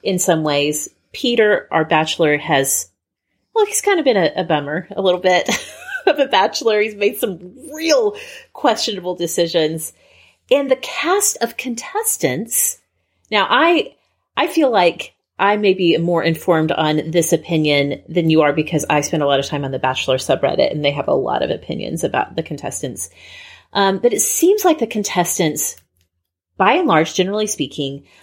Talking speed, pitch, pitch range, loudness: 170 wpm, 175 Hz, 155-240 Hz, -17 LUFS